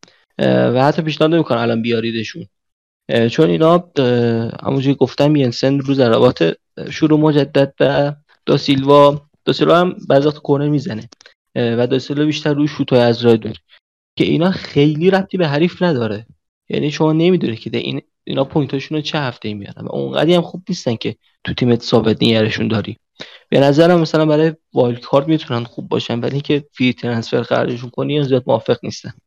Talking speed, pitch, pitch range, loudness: 160 wpm, 140 Hz, 120-155 Hz, -16 LUFS